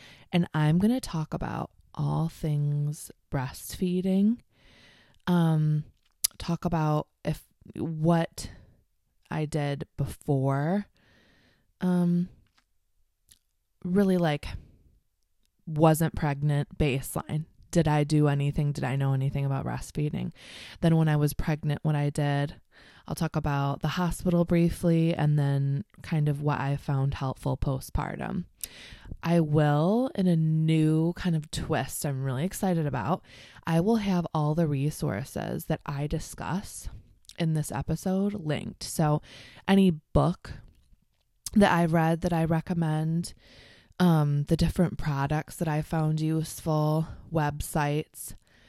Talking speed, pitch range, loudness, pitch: 120 wpm, 145-170 Hz, -28 LUFS, 155 Hz